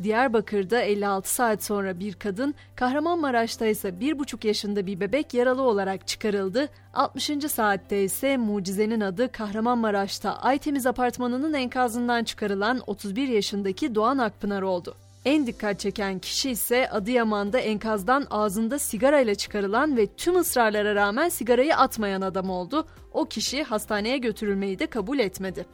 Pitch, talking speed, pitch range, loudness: 220 Hz, 130 wpm, 205-255 Hz, -25 LUFS